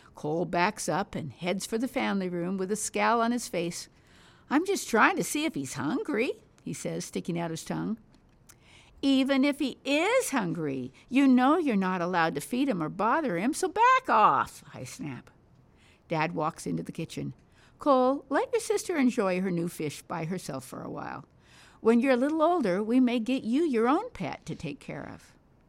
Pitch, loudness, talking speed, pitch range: 240 Hz, -28 LUFS, 195 wpm, 180-280 Hz